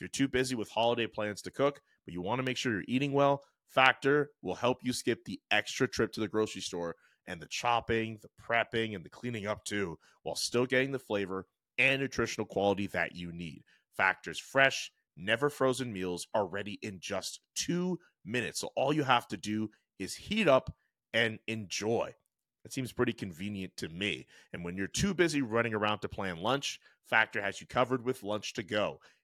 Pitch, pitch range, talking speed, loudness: 115 Hz, 100-130 Hz, 200 wpm, -32 LUFS